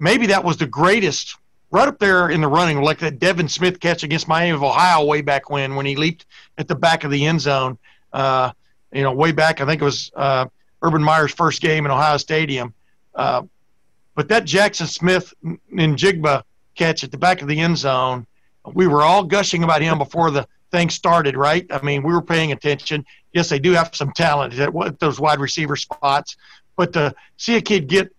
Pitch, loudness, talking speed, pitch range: 155 Hz, -18 LUFS, 210 wpm, 140-170 Hz